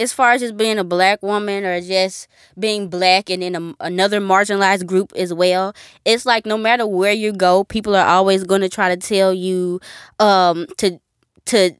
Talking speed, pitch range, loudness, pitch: 200 wpm, 185-210 Hz, -17 LUFS, 190 Hz